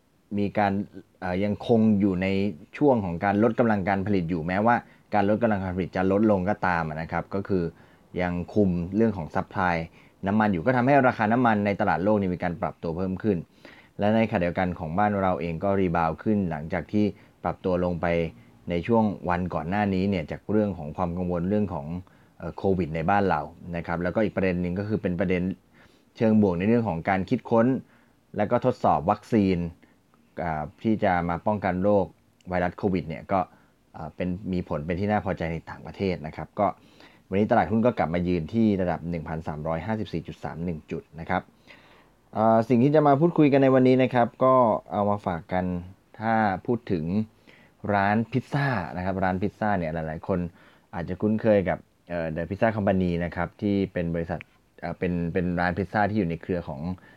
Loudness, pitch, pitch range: -25 LUFS, 95 Hz, 85-105 Hz